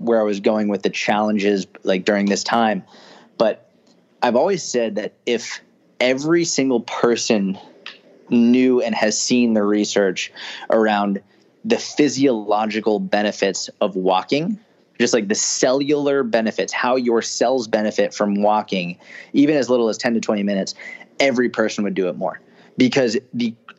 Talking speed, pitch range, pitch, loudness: 150 wpm, 105-125 Hz, 110 Hz, -19 LUFS